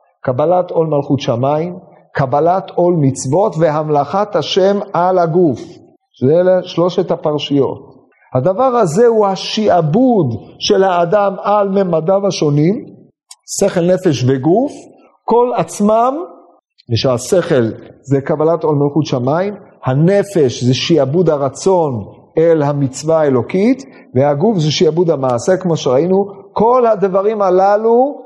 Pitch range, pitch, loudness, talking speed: 145-200 Hz, 175 Hz, -14 LUFS, 110 wpm